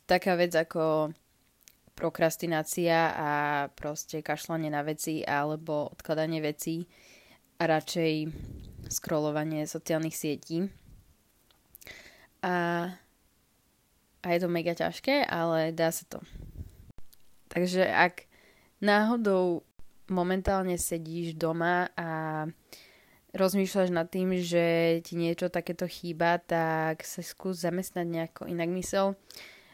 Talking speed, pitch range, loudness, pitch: 100 wpm, 155-180 Hz, -30 LUFS, 165 Hz